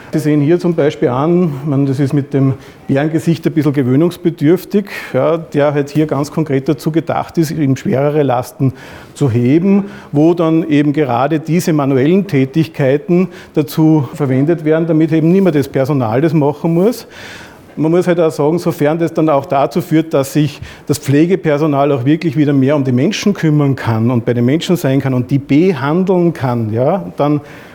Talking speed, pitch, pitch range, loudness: 180 wpm, 150 Hz, 140-165 Hz, -13 LUFS